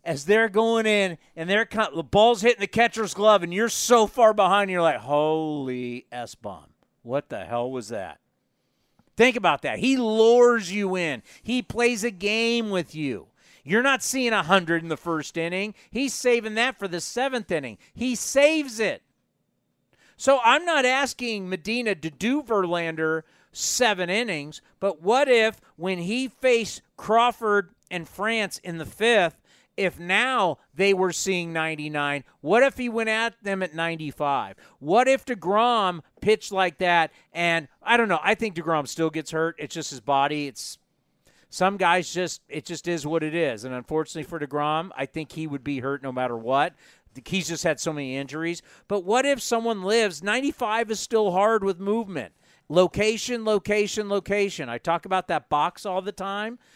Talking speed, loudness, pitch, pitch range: 175 wpm, -24 LUFS, 190 Hz, 160-225 Hz